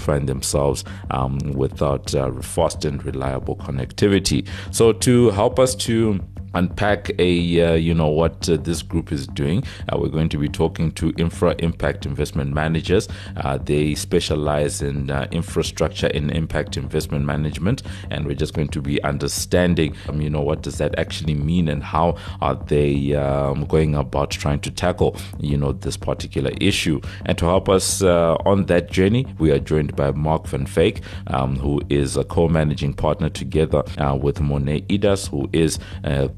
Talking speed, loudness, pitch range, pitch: 175 wpm, -21 LUFS, 70-90 Hz, 80 Hz